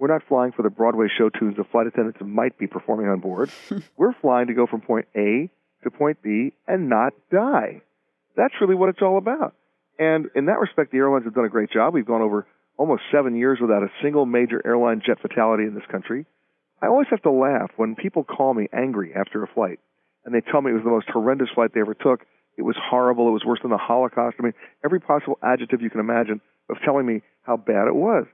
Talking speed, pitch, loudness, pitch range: 235 wpm, 115 Hz, -22 LUFS, 110-130 Hz